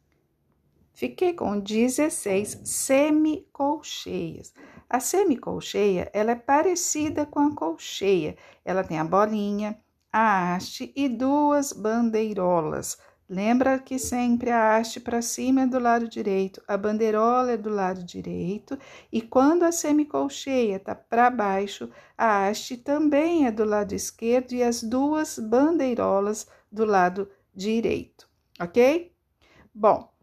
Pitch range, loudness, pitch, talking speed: 205-280 Hz, -24 LUFS, 235 Hz, 120 wpm